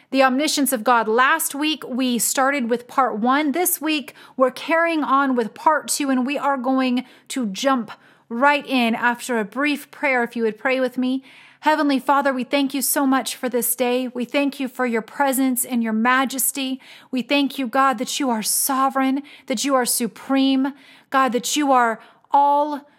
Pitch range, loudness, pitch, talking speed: 245-280 Hz, -20 LUFS, 265 Hz, 190 wpm